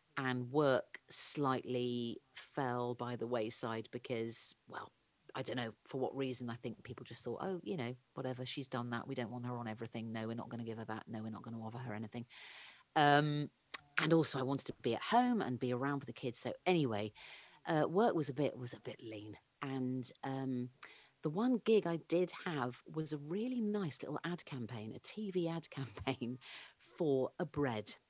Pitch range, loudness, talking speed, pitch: 120-145 Hz, -39 LUFS, 205 wpm, 125 Hz